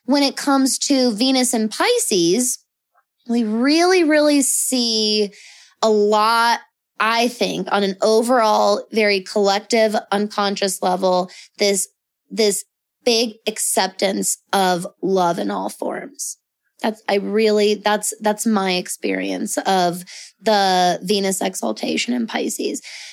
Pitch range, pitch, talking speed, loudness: 195-240 Hz, 215 Hz, 115 wpm, -18 LUFS